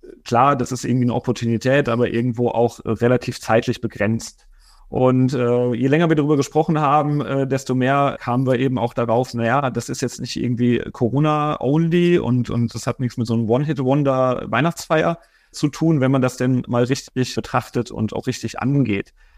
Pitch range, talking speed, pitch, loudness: 120-140 Hz, 180 wpm, 125 Hz, -19 LUFS